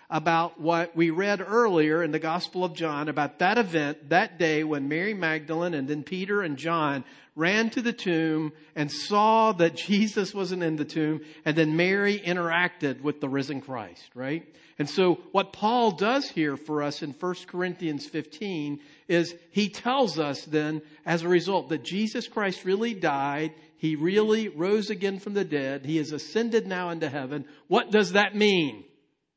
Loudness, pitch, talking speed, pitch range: -26 LUFS, 170 Hz, 175 wpm, 155-200 Hz